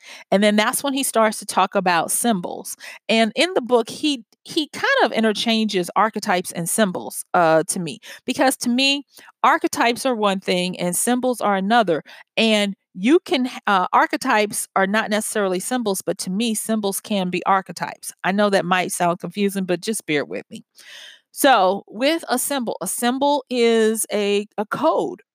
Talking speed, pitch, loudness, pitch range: 175 wpm, 215 Hz, -20 LUFS, 190-245 Hz